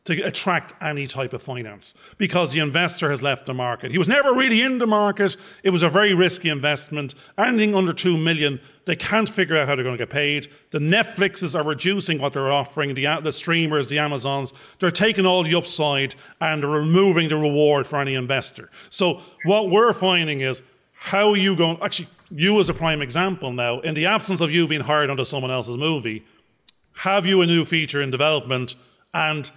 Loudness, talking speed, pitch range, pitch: -20 LUFS, 200 wpm, 140-185 Hz, 160 Hz